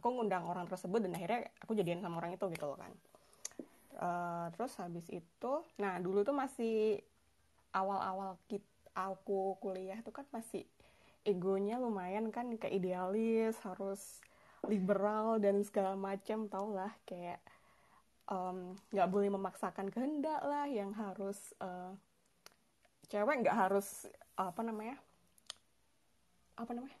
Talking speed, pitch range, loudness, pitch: 130 wpm, 185-225 Hz, -39 LUFS, 195 Hz